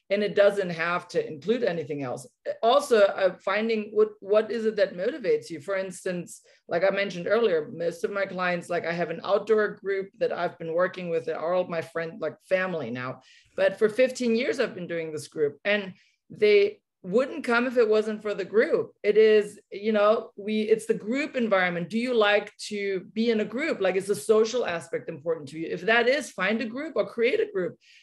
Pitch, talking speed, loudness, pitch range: 205 Hz, 215 wpm, -26 LUFS, 185-230 Hz